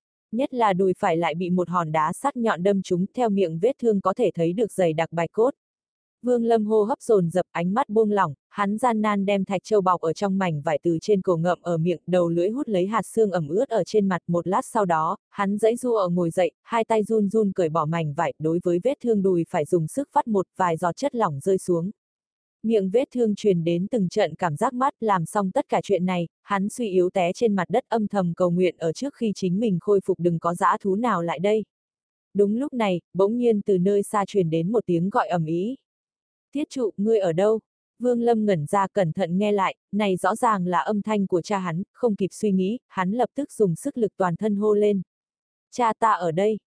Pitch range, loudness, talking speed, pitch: 180-220 Hz, -23 LUFS, 250 wpm, 195 Hz